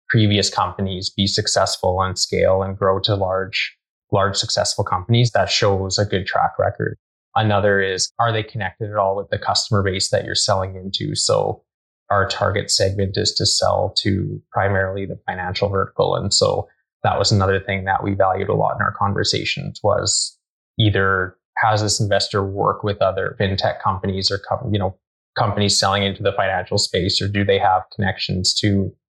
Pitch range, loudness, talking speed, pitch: 95-105 Hz, -19 LUFS, 175 wpm, 100 Hz